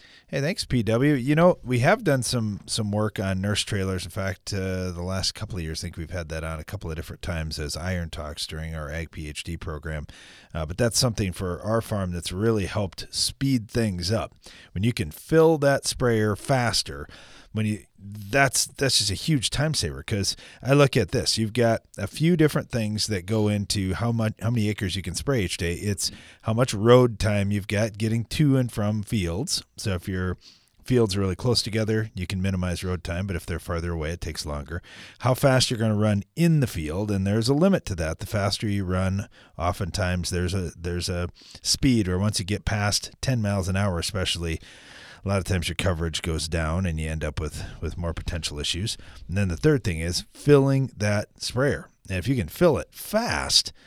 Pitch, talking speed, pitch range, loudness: 100 Hz, 215 wpm, 85-115 Hz, -25 LUFS